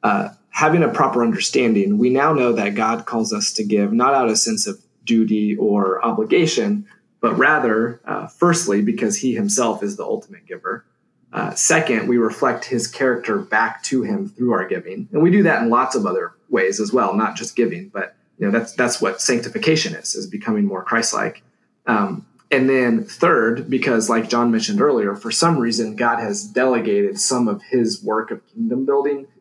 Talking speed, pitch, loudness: 190 wpm, 135 Hz, -19 LUFS